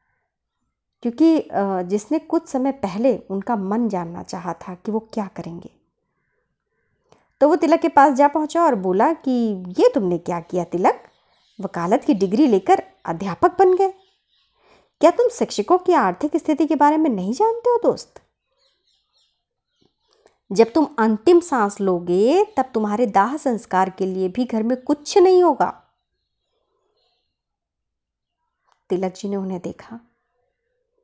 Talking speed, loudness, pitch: 135 wpm, -19 LUFS, 265 Hz